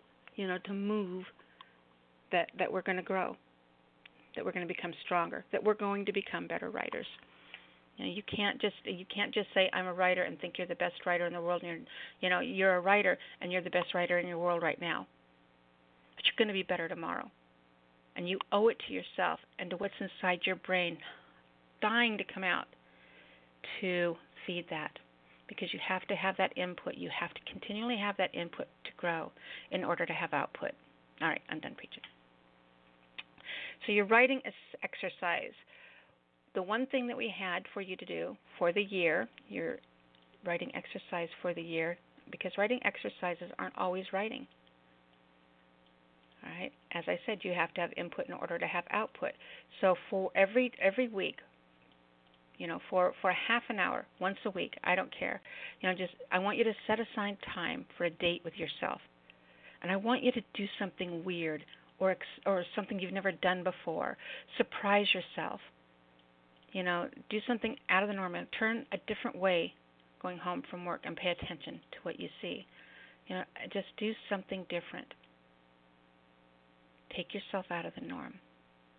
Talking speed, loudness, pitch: 185 wpm, -35 LUFS, 180 Hz